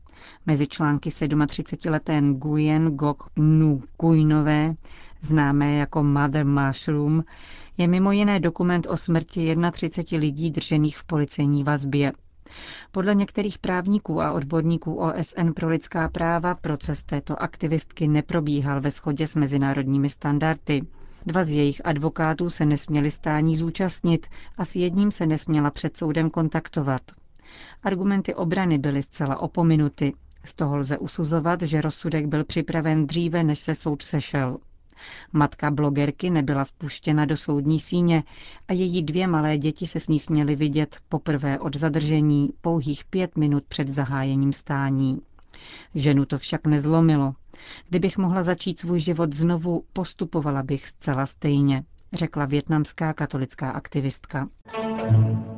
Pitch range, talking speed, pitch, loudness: 145-170 Hz, 125 wpm, 155 Hz, -24 LUFS